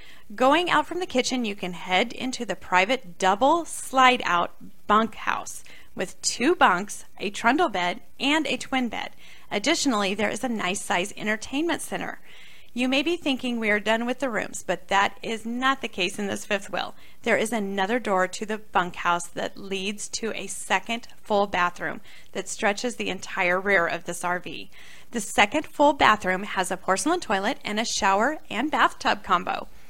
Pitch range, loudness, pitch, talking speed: 190-255 Hz, -25 LUFS, 210 Hz, 180 wpm